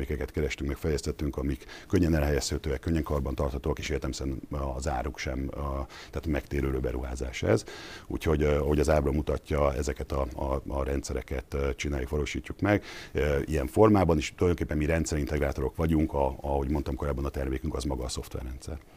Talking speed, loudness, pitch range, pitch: 160 wpm, -30 LUFS, 70-80 Hz, 75 Hz